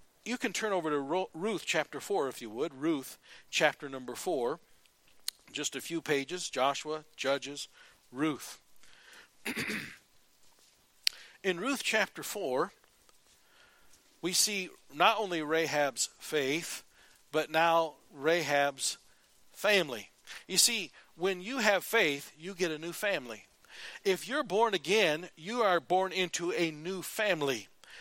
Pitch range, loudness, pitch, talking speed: 150-200 Hz, -32 LUFS, 170 Hz, 125 wpm